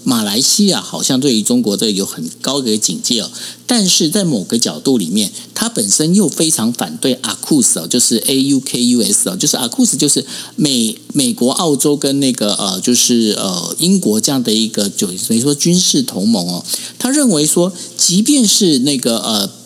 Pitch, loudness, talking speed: 175 Hz, -13 LUFS, 280 characters per minute